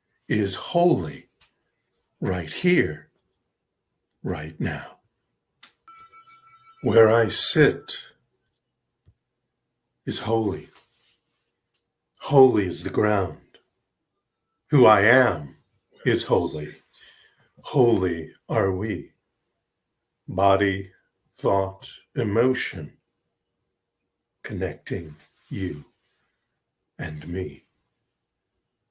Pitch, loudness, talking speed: 110 Hz, -22 LUFS, 60 wpm